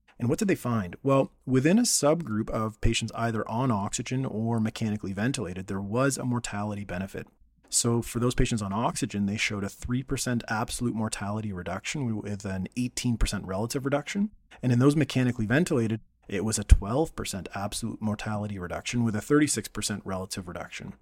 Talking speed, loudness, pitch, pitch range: 165 wpm, -28 LUFS, 115 Hz, 100-125 Hz